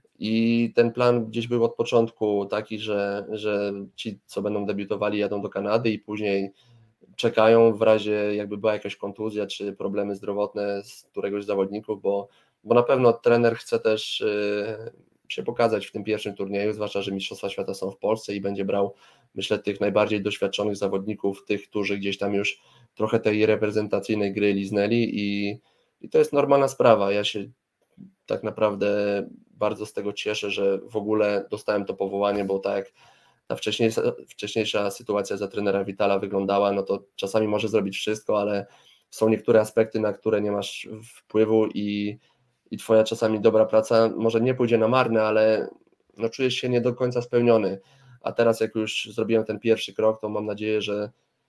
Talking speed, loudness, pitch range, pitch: 170 wpm, -24 LUFS, 100-110 Hz, 105 Hz